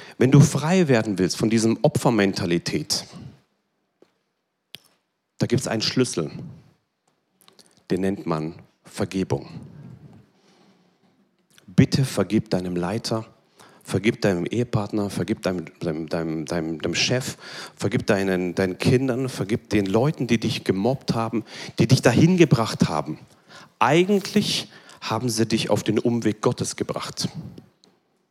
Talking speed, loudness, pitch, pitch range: 115 wpm, -22 LUFS, 115 Hz, 95-130 Hz